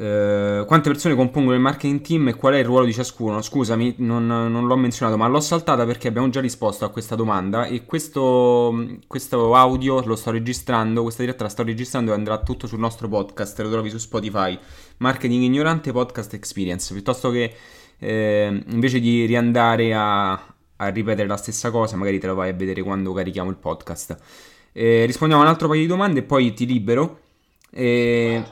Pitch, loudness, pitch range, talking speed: 115 Hz, -20 LUFS, 105-130 Hz, 185 wpm